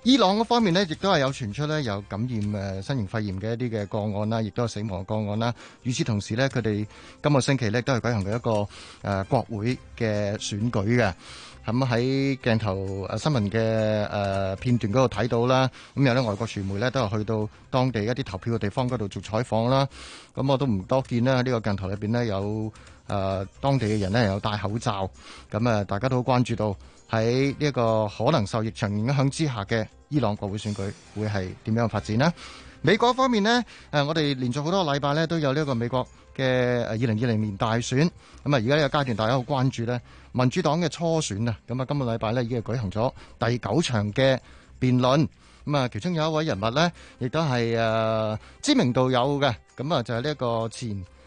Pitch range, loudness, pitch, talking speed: 105-135 Hz, -25 LUFS, 120 Hz, 310 characters per minute